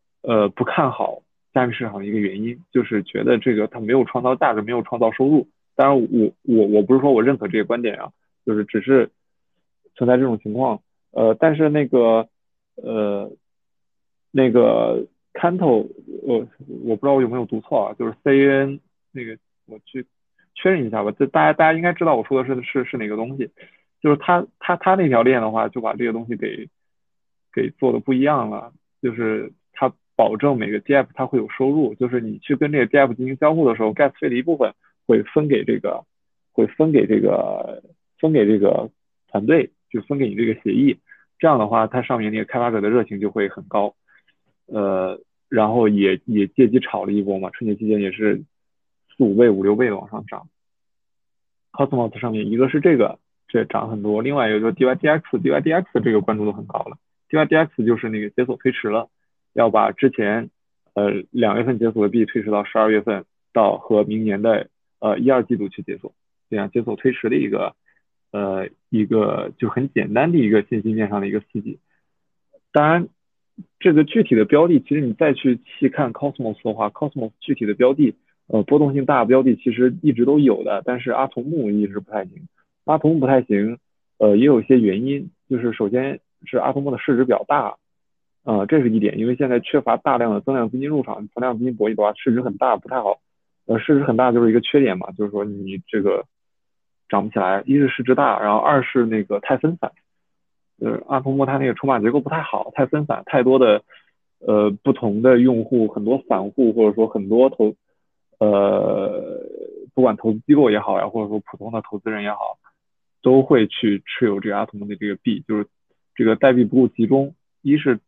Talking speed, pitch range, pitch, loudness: 305 characters per minute, 110-135 Hz, 120 Hz, -19 LUFS